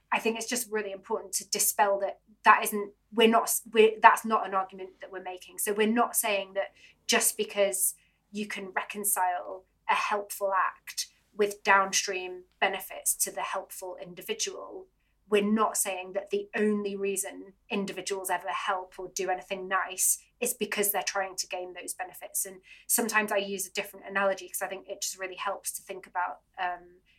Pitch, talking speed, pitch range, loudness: 195 Hz, 180 wpm, 185-210 Hz, -28 LUFS